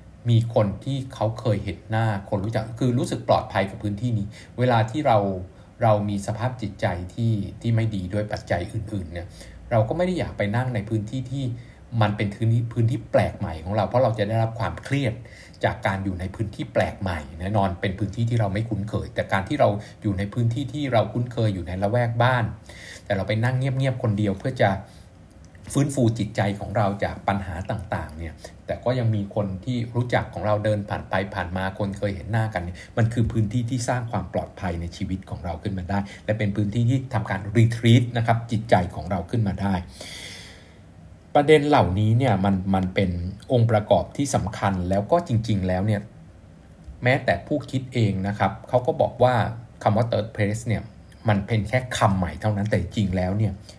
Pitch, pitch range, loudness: 105 Hz, 95-115 Hz, -24 LUFS